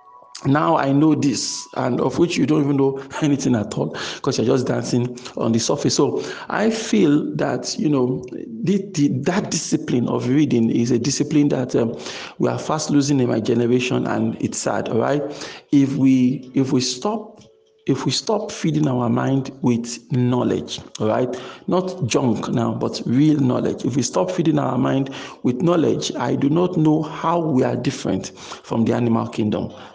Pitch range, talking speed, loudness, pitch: 125-155 Hz, 180 wpm, -20 LUFS, 135 Hz